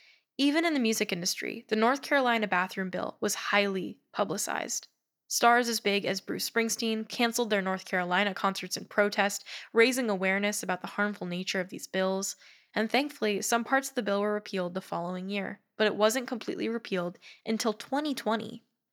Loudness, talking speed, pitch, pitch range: -29 LUFS, 170 wpm, 210 Hz, 190-235 Hz